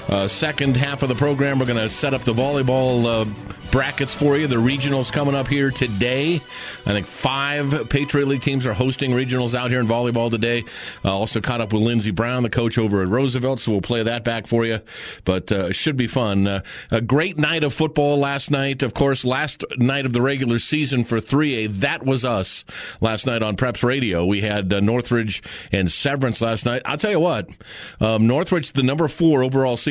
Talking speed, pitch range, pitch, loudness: 215 wpm, 115-140 Hz, 125 Hz, -20 LUFS